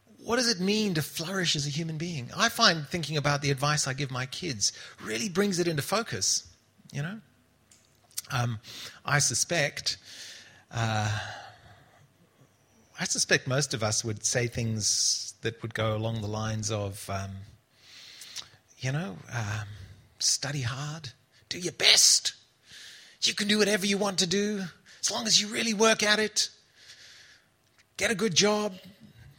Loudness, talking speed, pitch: -27 LUFS, 155 wpm, 140 Hz